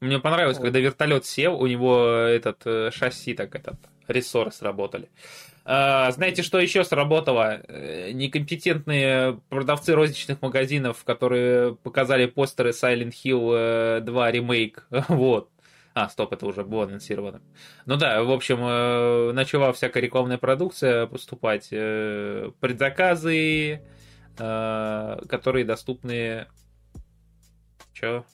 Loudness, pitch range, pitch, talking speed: -23 LUFS, 115-140 Hz, 125 Hz, 105 wpm